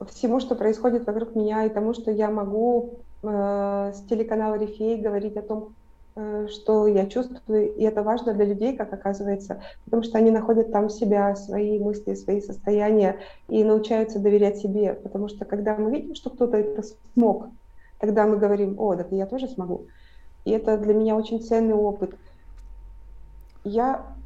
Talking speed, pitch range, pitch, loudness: 165 wpm, 205-220 Hz, 215 Hz, -24 LUFS